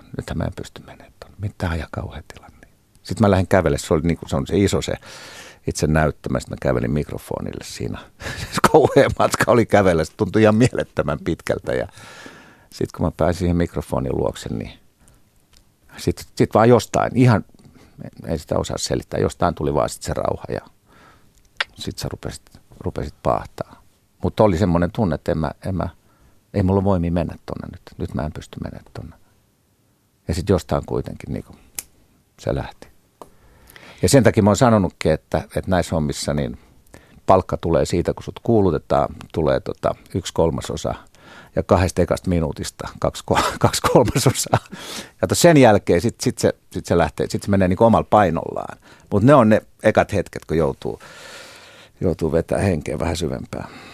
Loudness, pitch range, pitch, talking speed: -20 LUFS, 85-110 Hz, 95 Hz, 165 wpm